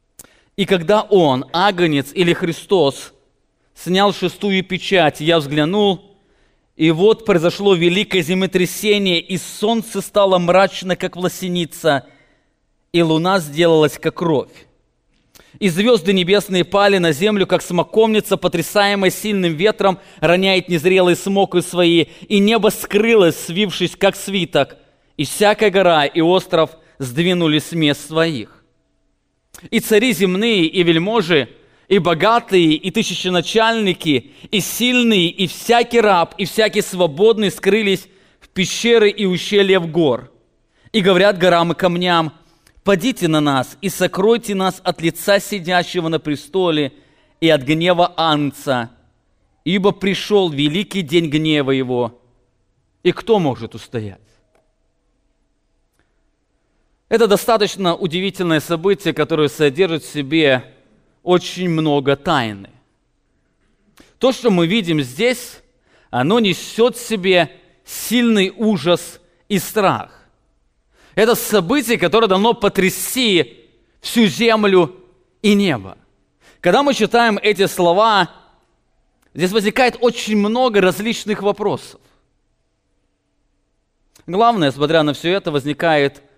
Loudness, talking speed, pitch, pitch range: -16 LUFS, 110 wpm, 180 Hz, 160-205 Hz